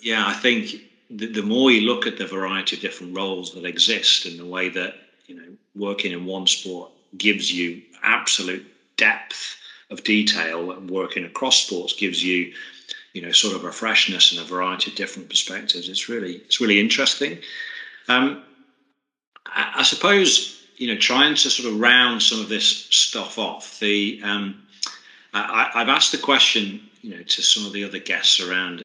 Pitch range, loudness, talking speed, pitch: 90-120 Hz, -19 LUFS, 180 wpm, 100 Hz